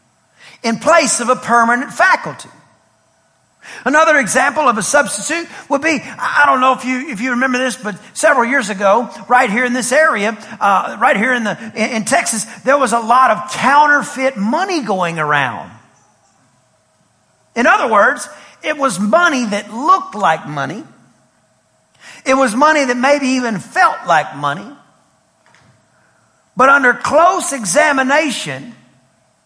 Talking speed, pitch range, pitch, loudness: 135 wpm, 210-285 Hz, 250 Hz, -14 LUFS